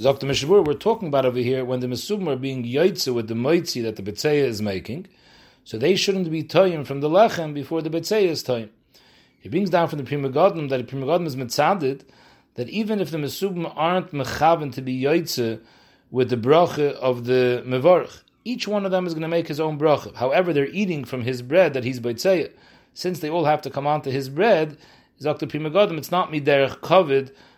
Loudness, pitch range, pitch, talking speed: -22 LUFS, 130-175 Hz, 150 Hz, 210 wpm